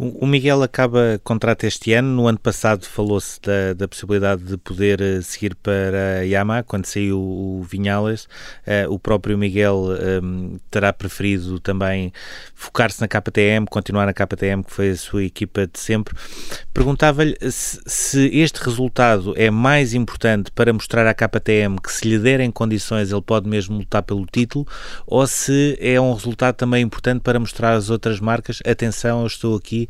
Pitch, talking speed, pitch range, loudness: 110 Hz, 170 wpm, 100-120 Hz, -19 LUFS